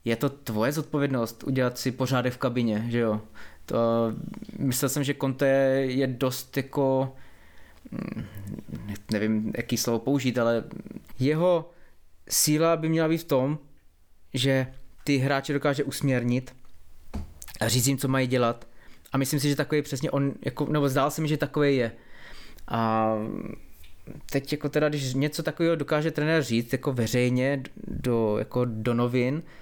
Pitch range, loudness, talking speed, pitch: 115-145 Hz, -26 LUFS, 150 wpm, 130 Hz